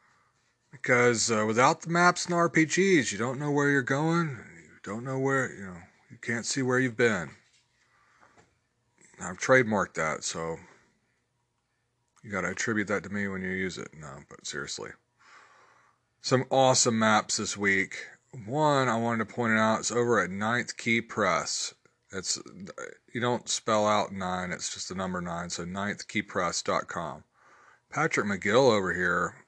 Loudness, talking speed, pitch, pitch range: -27 LUFS, 160 wpm, 120 Hz, 105-130 Hz